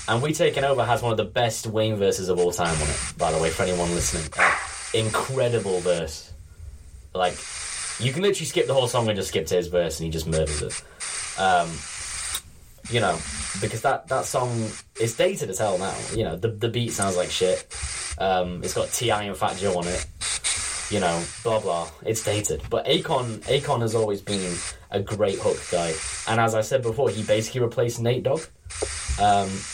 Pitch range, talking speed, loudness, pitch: 85-115 Hz, 200 wpm, -24 LUFS, 95 Hz